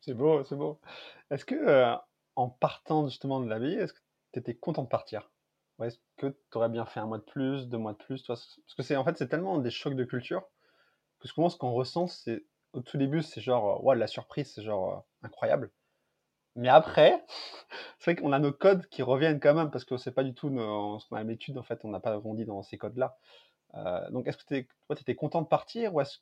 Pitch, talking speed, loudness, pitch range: 130 Hz, 245 wpm, -30 LUFS, 115-150 Hz